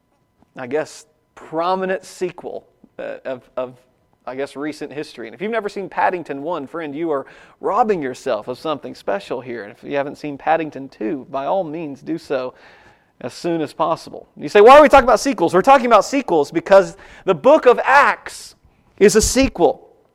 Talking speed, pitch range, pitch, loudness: 185 wpm, 140-195 Hz, 160 Hz, -17 LUFS